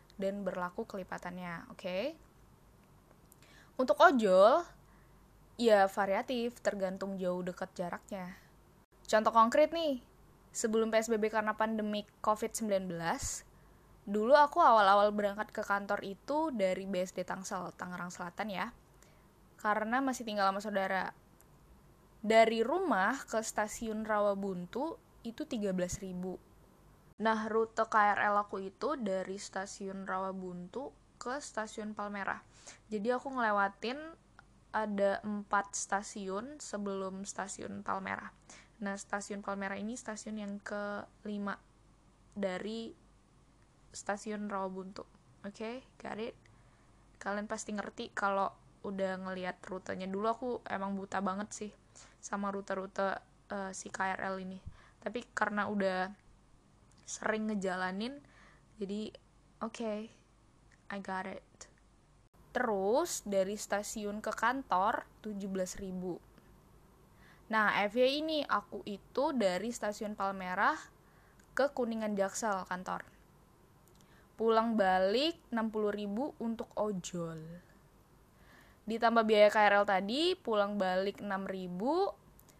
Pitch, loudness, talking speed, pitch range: 205 Hz, -34 LUFS, 100 wpm, 190-225 Hz